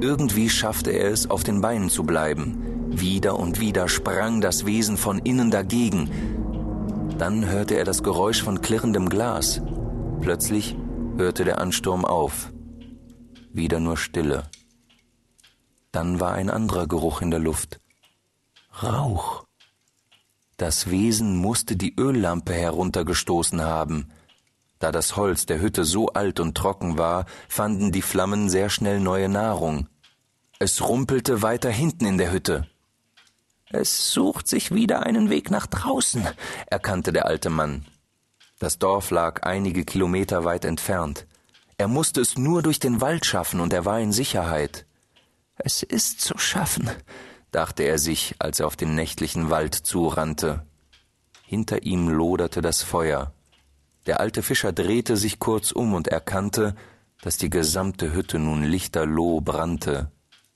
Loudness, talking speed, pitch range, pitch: -23 LUFS, 140 wpm, 80-110 Hz, 95 Hz